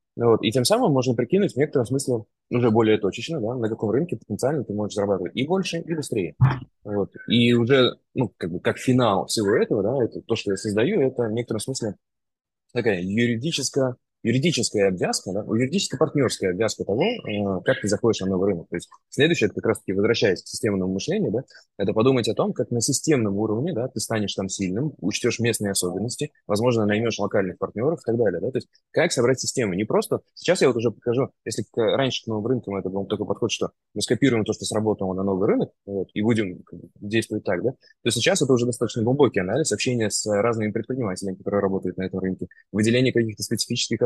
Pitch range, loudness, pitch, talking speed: 100-125 Hz, -23 LUFS, 110 Hz, 205 wpm